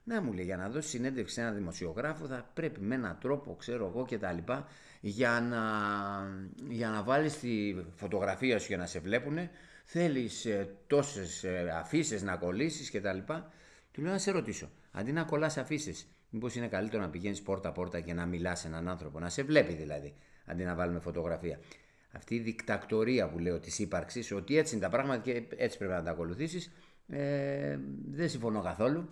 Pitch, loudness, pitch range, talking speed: 105 Hz, -35 LUFS, 90-135 Hz, 190 wpm